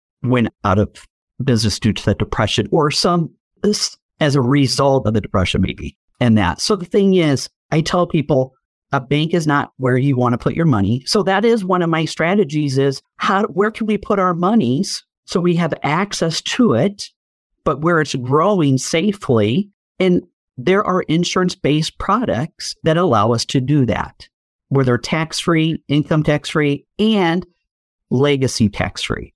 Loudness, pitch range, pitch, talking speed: -17 LUFS, 130-185 Hz, 155 Hz, 175 wpm